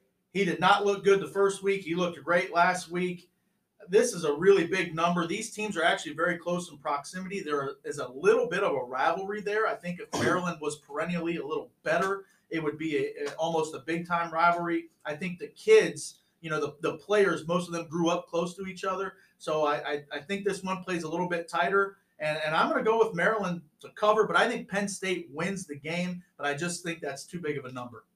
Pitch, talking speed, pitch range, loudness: 175 Hz, 240 wpm, 165-200 Hz, -29 LUFS